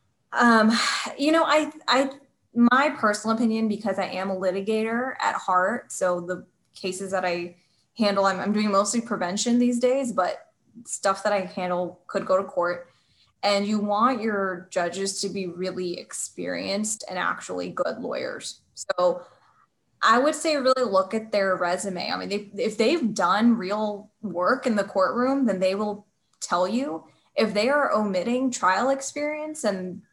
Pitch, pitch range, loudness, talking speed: 205 Hz, 185-240 Hz, -24 LUFS, 165 wpm